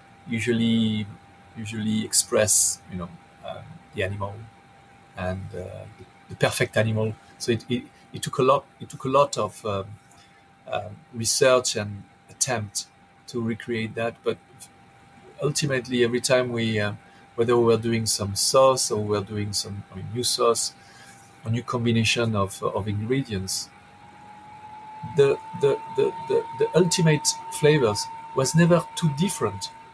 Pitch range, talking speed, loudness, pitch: 105-140 Hz, 150 wpm, -24 LUFS, 115 Hz